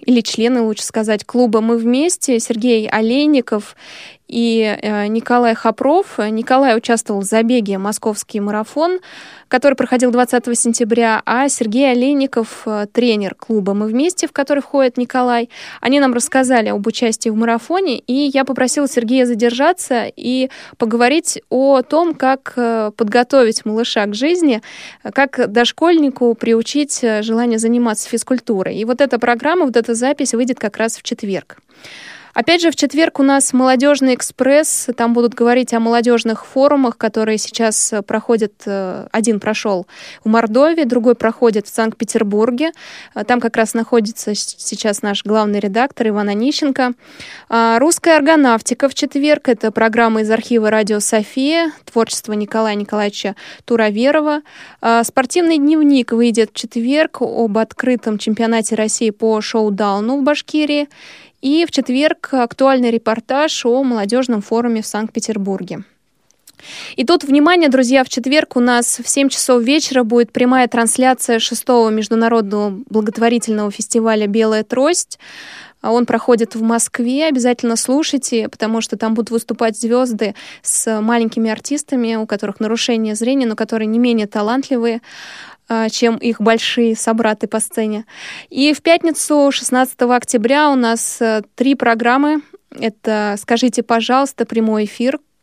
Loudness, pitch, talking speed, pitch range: -15 LUFS, 235 Hz, 135 wpm, 225-265 Hz